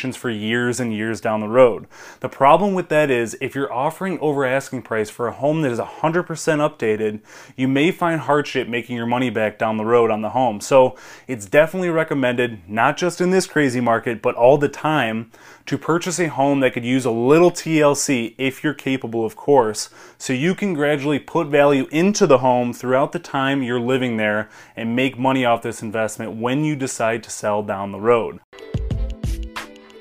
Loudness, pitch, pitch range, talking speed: -19 LUFS, 130 Hz, 115-150 Hz, 195 wpm